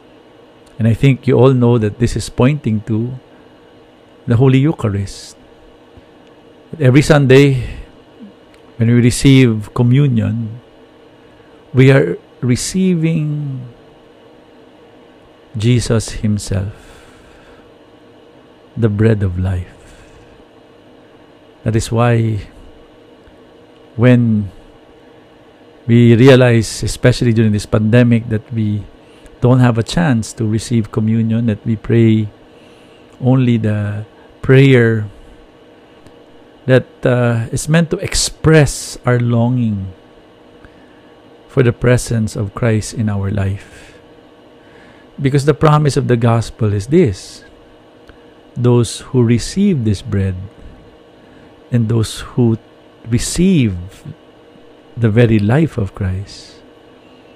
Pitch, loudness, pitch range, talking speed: 115 Hz, -14 LUFS, 105-130 Hz, 95 wpm